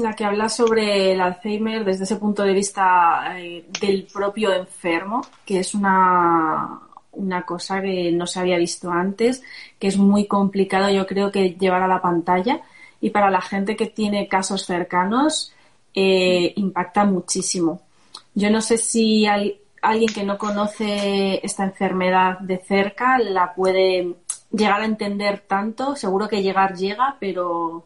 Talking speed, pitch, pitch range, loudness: 155 wpm, 195 Hz, 185-210 Hz, -20 LUFS